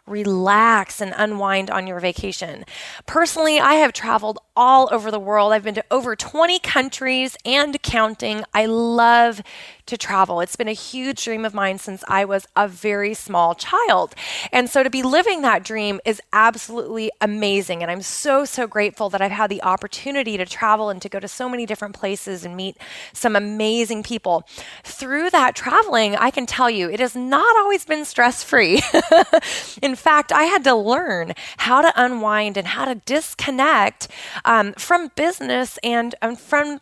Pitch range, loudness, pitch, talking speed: 205-265 Hz, -18 LUFS, 225 Hz, 175 wpm